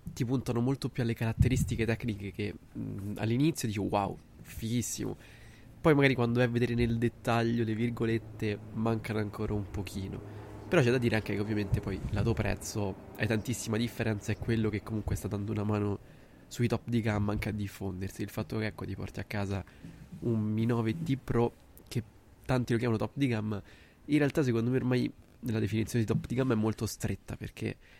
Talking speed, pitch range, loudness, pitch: 195 wpm, 105-120 Hz, -32 LUFS, 110 Hz